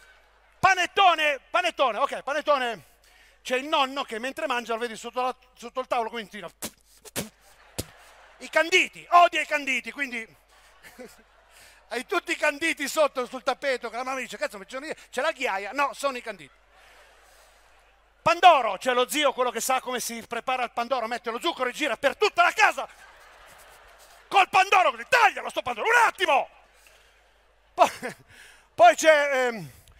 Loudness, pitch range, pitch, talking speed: -24 LUFS, 240-320 Hz, 265 Hz, 155 wpm